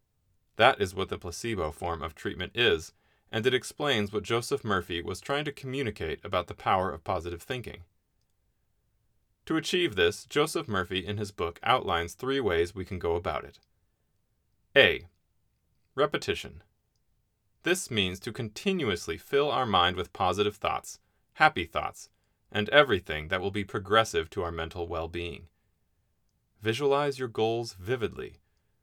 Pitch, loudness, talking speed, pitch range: 105 Hz, -29 LUFS, 145 wpm, 90-120 Hz